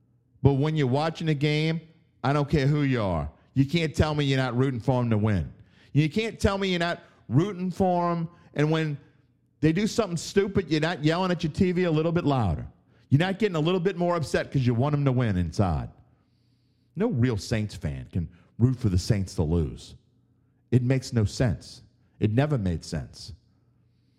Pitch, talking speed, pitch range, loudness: 135 Hz, 205 wpm, 115-160 Hz, -26 LUFS